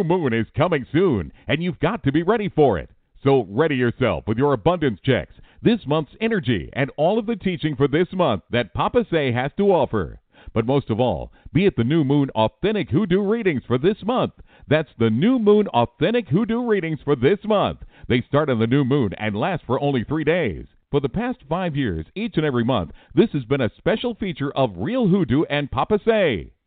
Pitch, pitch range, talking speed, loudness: 145 Hz, 125-195 Hz, 210 wpm, -21 LUFS